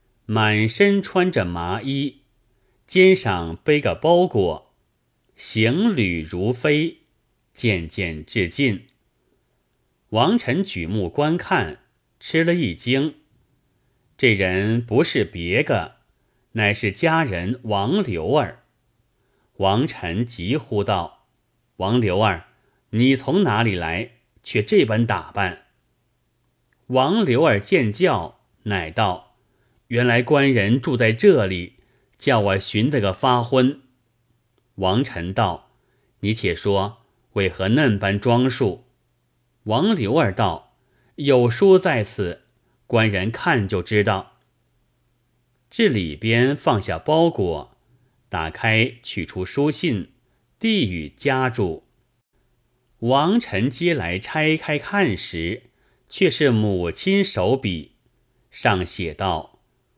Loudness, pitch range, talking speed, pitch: -20 LUFS, 100-135 Hz, 145 characters per minute, 120 Hz